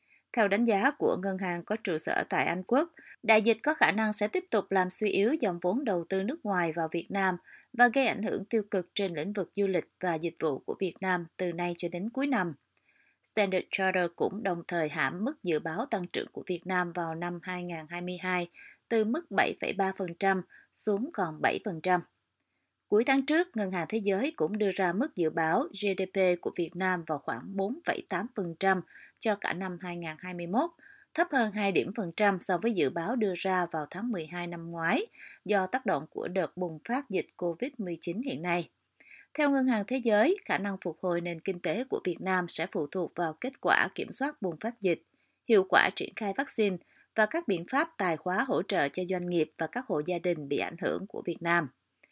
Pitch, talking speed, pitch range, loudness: 190 Hz, 210 wpm, 175-220 Hz, -30 LUFS